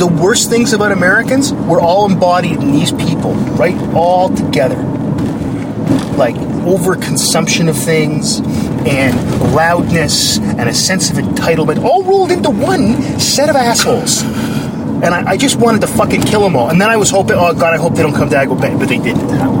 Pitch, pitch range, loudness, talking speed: 205 Hz, 180-230 Hz, -11 LUFS, 175 wpm